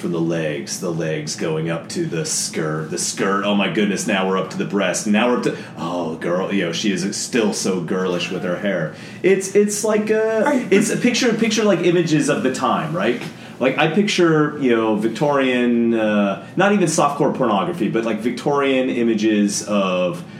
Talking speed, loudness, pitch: 195 wpm, -19 LUFS, 140 Hz